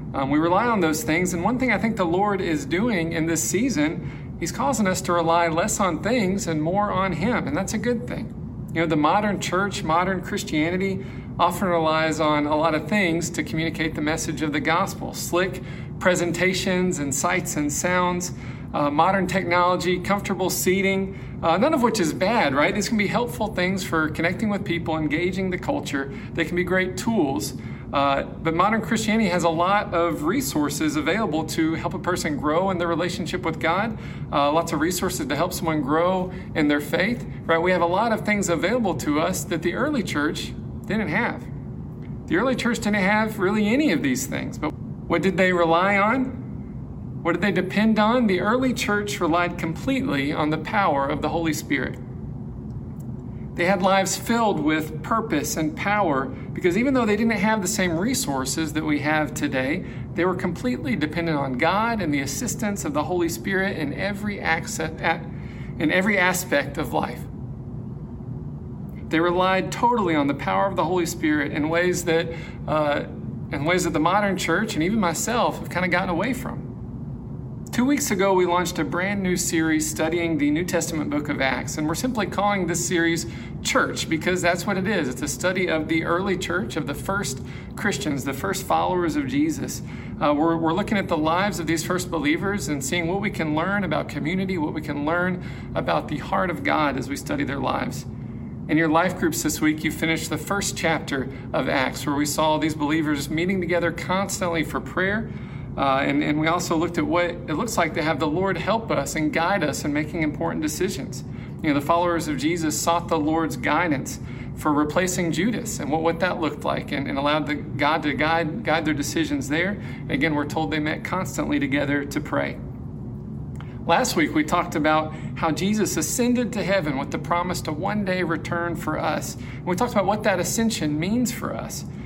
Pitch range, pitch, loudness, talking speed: 155-185 Hz, 170 Hz, -23 LUFS, 195 wpm